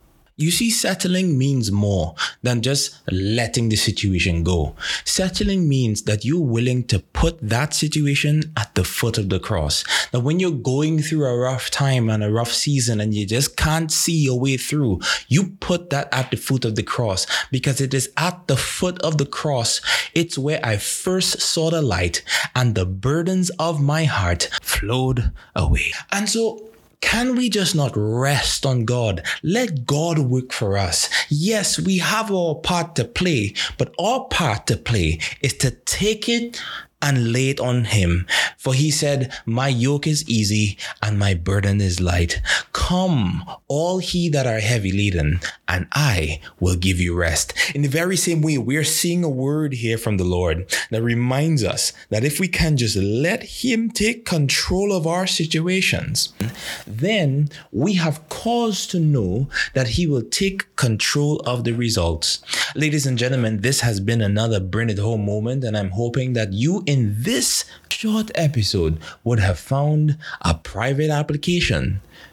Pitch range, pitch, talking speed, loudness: 110-160 Hz, 135 Hz, 175 wpm, -20 LUFS